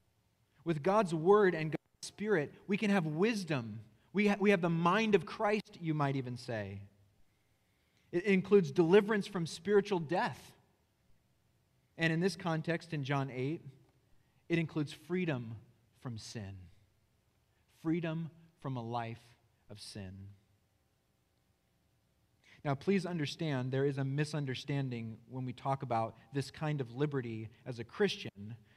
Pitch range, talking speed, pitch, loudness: 115-170 Hz, 135 wpm, 140 Hz, -34 LUFS